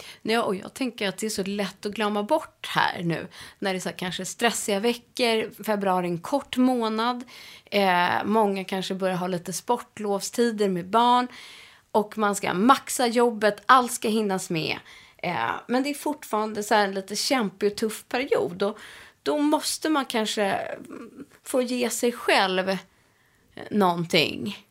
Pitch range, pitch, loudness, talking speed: 195-245 Hz, 215 Hz, -25 LUFS, 165 wpm